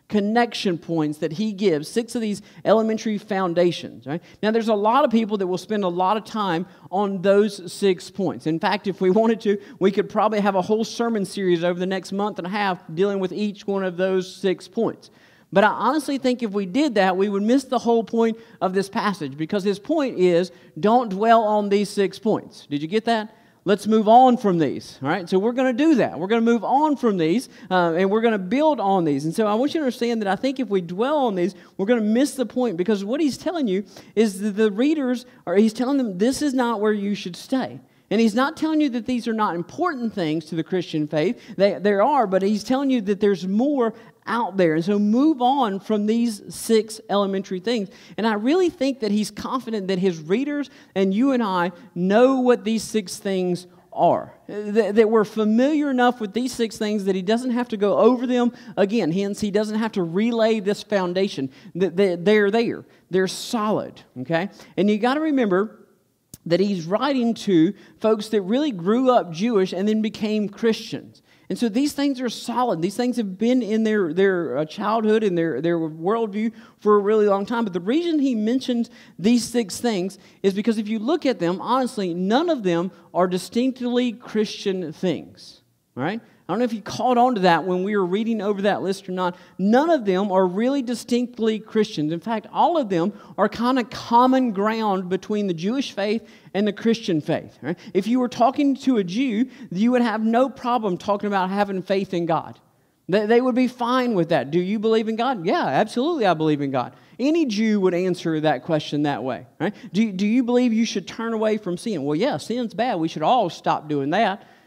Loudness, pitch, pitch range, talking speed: -22 LUFS, 210 Hz, 185-235 Hz, 220 wpm